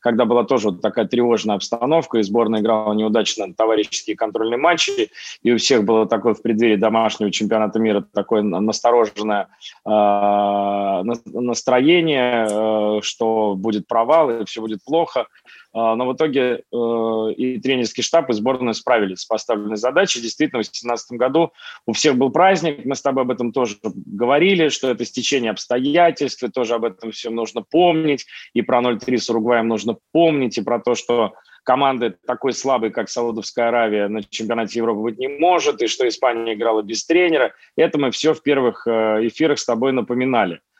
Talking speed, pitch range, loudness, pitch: 170 wpm, 110-130 Hz, -19 LUFS, 120 Hz